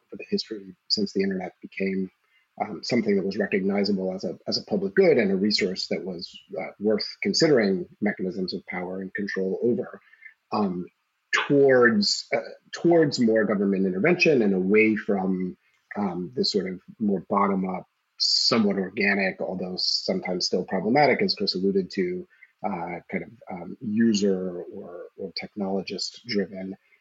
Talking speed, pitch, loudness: 150 wpm, 110 Hz, -24 LUFS